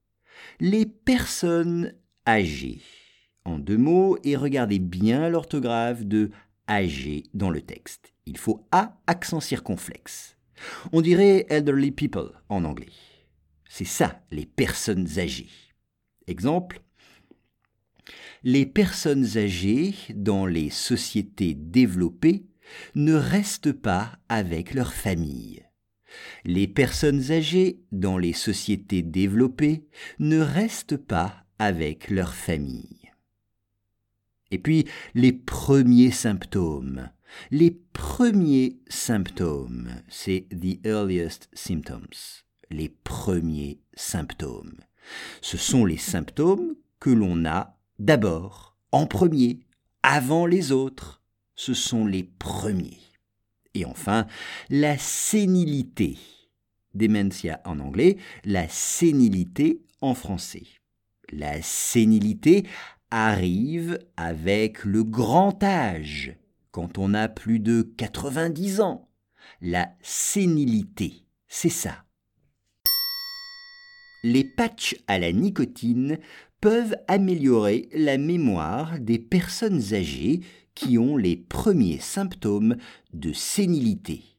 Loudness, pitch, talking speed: -24 LUFS, 115 Hz, 100 wpm